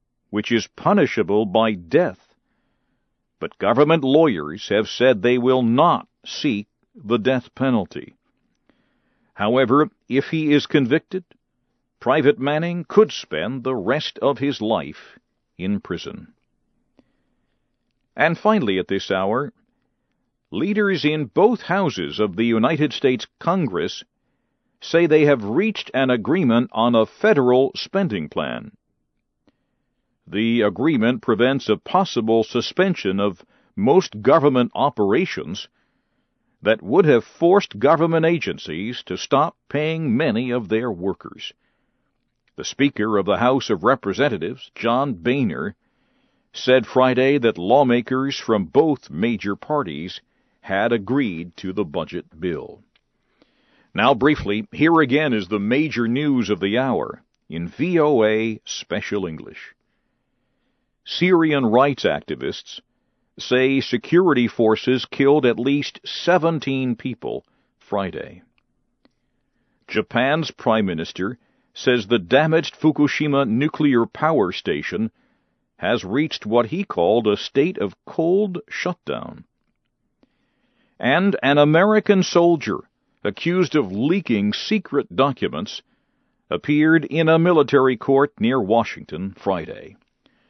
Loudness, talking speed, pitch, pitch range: -20 LUFS, 110 wpm, 135 Hz, 115-160 Hz